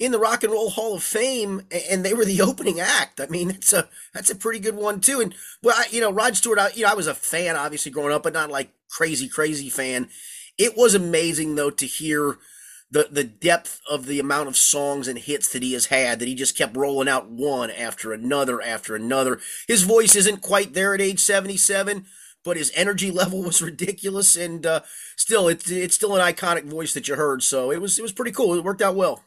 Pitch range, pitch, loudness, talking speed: 145-200 Hz, 175 Hz, -21 LUFS, 235 wpm